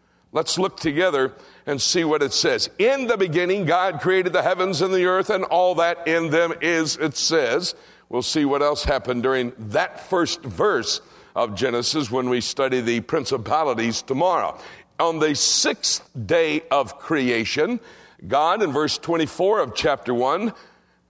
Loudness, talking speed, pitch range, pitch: -21 LUFS, 160 wpm, 125-185 Hz, 160 Hz